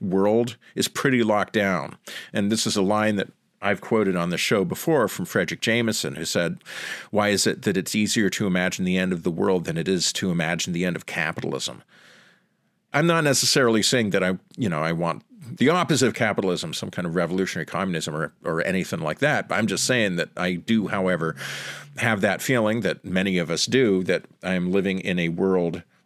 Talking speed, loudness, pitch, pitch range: 205 wpm, -23 LUFS, 95 Hz, 85-105 Hz